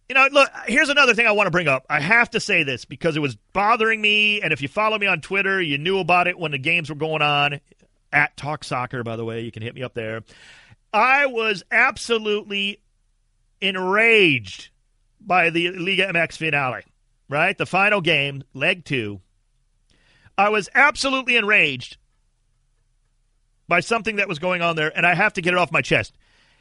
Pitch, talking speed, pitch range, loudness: 165 Hz, 190 wpm, 125-200 Hz, -19 LUFS